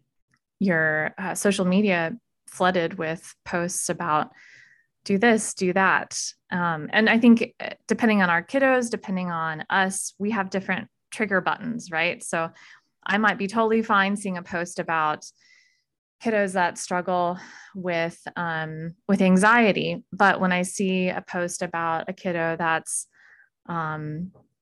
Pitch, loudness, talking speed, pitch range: 185 Hz, -24 LUFS, 140 wpm, 170-205 Hz